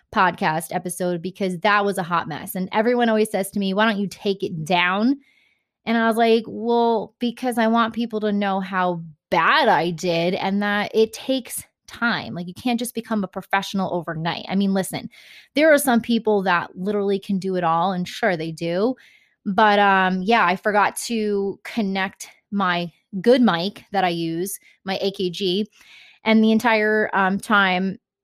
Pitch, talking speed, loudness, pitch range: 200 Hz, 180 wpm, -21 LUFS, 185-225 Hz